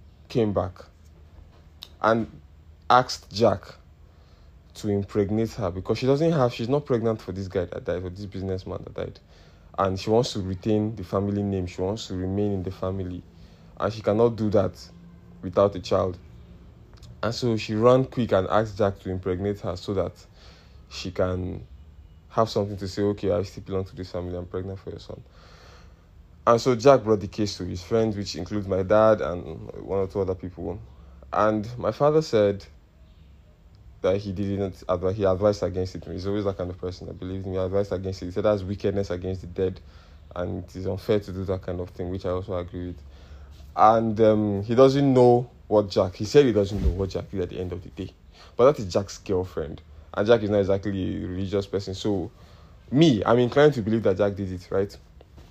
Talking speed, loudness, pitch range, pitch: 205 wpm, -25 LUFS, 90-105 Hz, 95 Hz